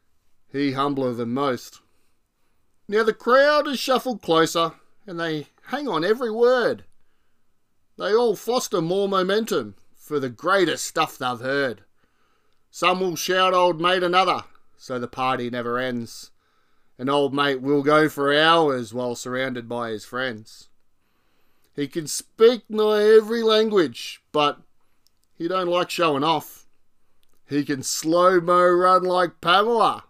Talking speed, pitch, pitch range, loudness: 135 wpm, 145 Hz, 120-185 Hz, -21 LUFS